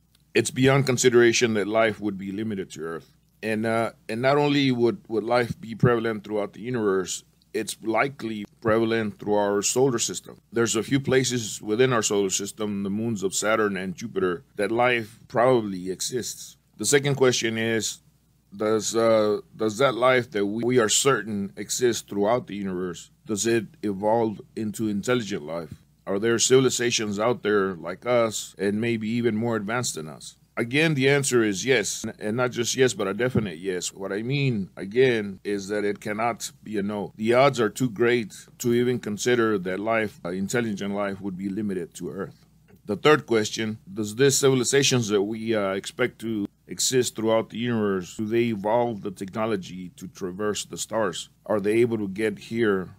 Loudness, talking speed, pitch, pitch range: -24 LUFS, 180 wpm, 110 Hz, 105-120 Hz